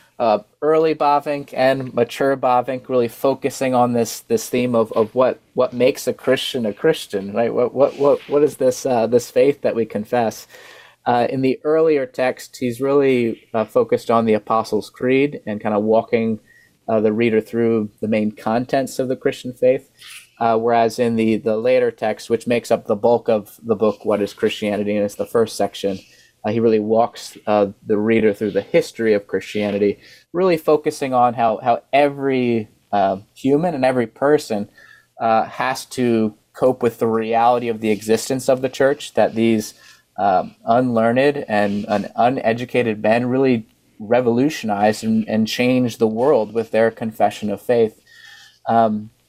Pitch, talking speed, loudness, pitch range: 120 Hz, 175 wpm, -19 LUFS, 110-135 Hz